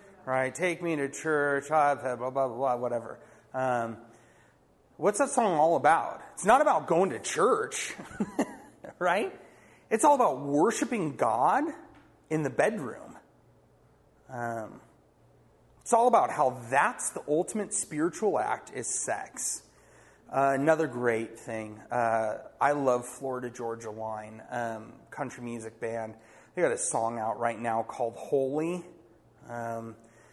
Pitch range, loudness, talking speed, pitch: 115-155 Hz, -29 LUFS, 130 wpm, 130 Hz